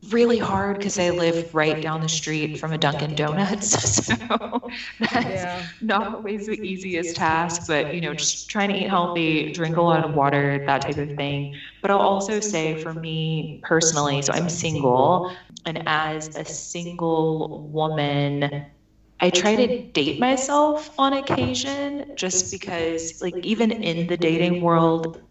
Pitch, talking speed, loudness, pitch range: 165 Hz, 160 wpm, -22 LUFS, 155-200 Hz